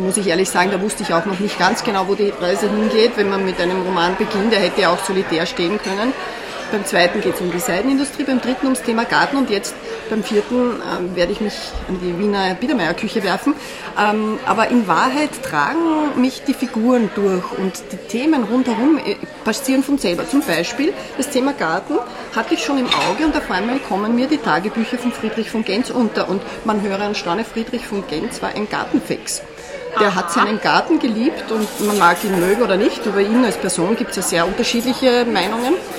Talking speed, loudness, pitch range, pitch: 205 wpm, -18 LUFS, 190-250 Hz, 220 Hz